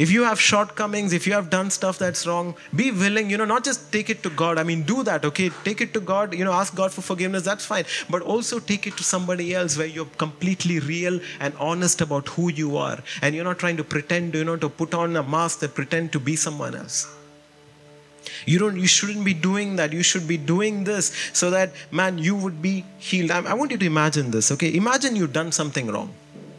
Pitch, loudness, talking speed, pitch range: 180 Hz, -23 LUFS, 235 wpm, 160-200 Hz